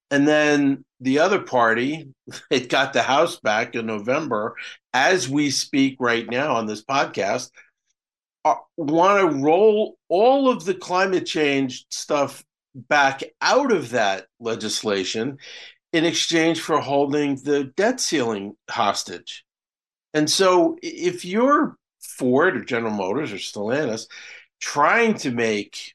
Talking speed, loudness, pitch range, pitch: 125 wpm, -21 LUFS, 125-185 Hz, 150 Hz